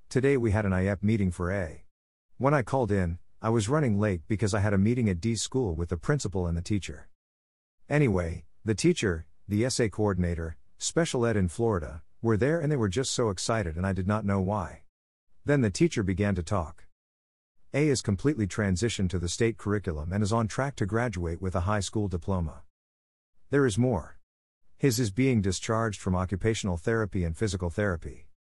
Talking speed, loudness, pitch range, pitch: 195 wpm, -28 LUFS, 85-115 Hz, 100 Hz